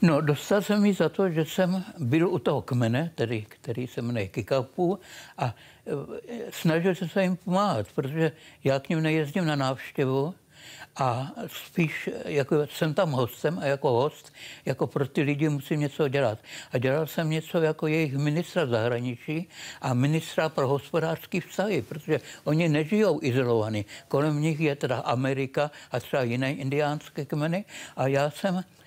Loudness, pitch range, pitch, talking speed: -27 LUFS, 135-165 Hz, 150 Hz, 160 wpm